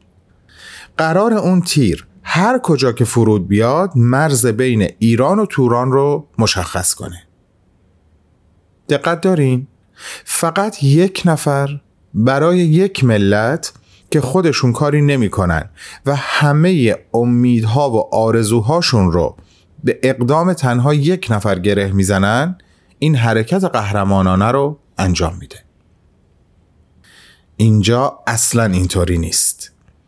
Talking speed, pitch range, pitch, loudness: 100 wpm, 95-145 Hz, 120 Hz, -14 LUFS